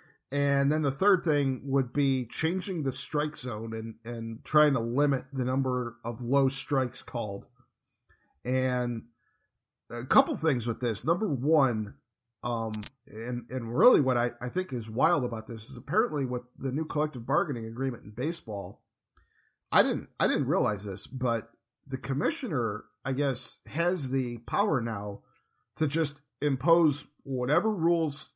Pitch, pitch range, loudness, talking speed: 130 Hz, 120-145 Hz, -29 LUFS, 150 wpm